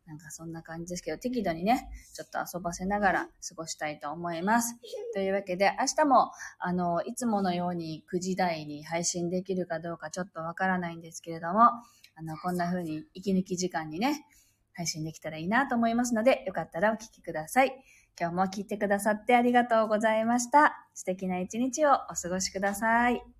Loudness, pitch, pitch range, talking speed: -29 LUFS, 185 Hz, 170-230 Hz, 410 characters per minute